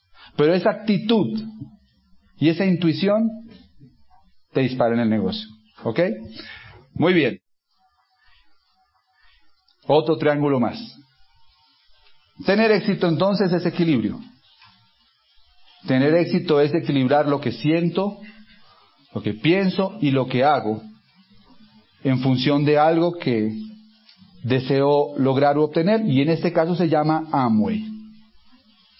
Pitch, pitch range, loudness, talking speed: 165 Hz, 135-205 Hz, -20 LUFS, 110 wpm